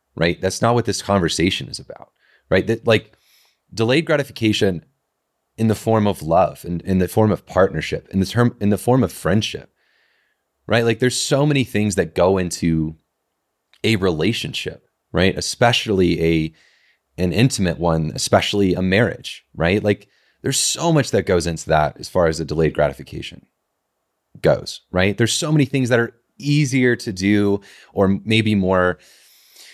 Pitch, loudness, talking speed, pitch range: 100 Hz, -19 LUFS, 165 wpm, 90-115 Hz